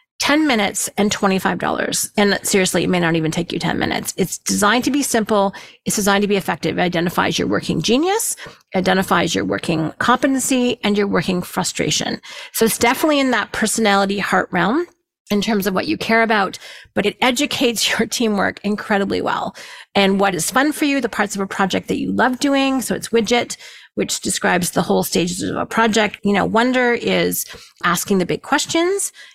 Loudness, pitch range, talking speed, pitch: -18 LUFS, 195-250 Hz, 190 wpm, 210 Hz